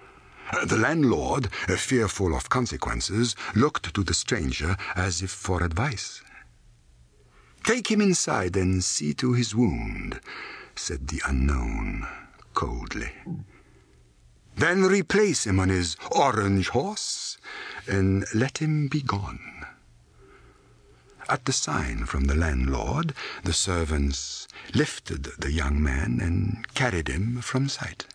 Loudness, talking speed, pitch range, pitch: -26 LUFS, 115 wpm, 70-120 Hz, 95 Hz